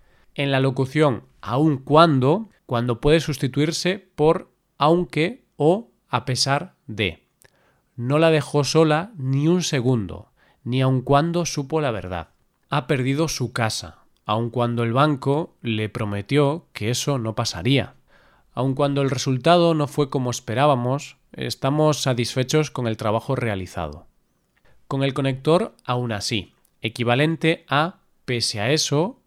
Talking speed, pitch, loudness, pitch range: 135 wpm, 135 Hz, -22 LUFS, 120-150 Hz